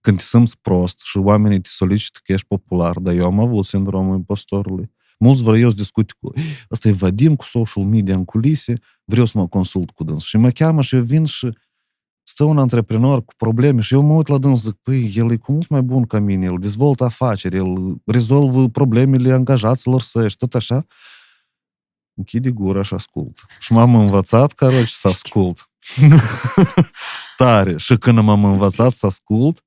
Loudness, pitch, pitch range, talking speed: -16 LUFS, 115 Hz, 100-130 Hz, 190 wpm